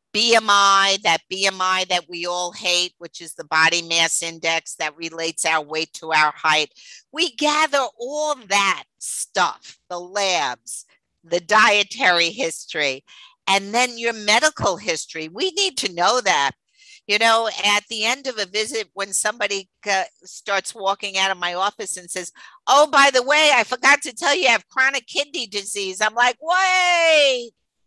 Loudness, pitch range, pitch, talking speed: -19 LUFS, 175-255 Hz, 200 Hz, 160 wpm